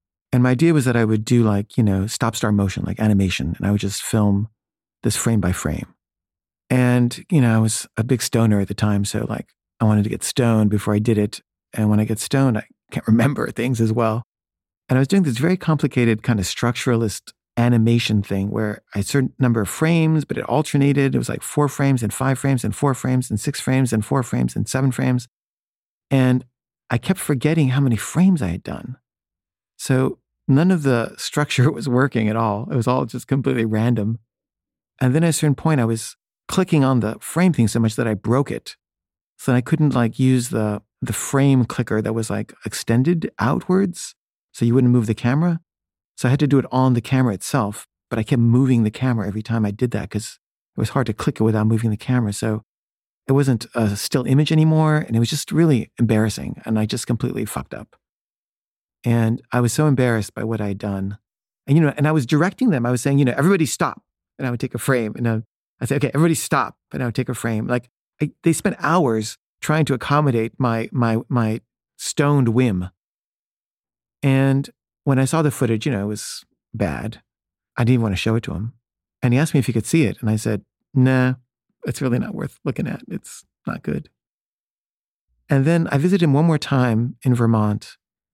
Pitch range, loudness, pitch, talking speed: 110-135 Hz, -20 LUFS, 120 Hz, 220 wpm